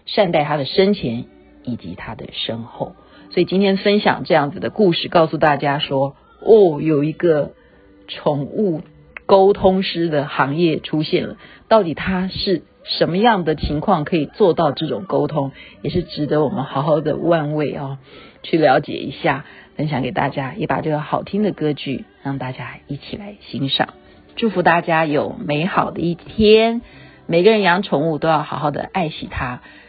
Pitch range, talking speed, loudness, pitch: 140-185 Hz, 250 characters per minute, -18 LUFS, 155 Hz